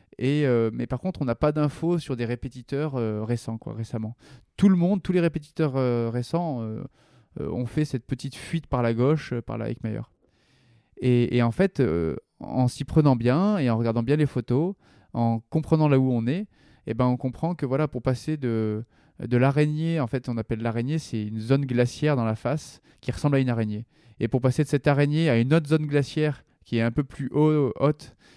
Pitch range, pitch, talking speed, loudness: 120-150 Hz, 130 Hz, 220 wpm, -25 LUFS